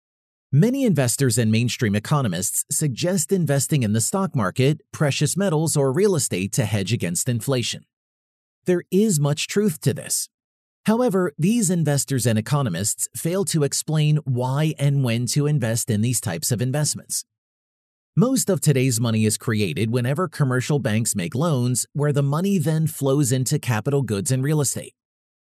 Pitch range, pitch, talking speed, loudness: 120-155 Hz, 140 Hz, 155 wpm, -21 LUFS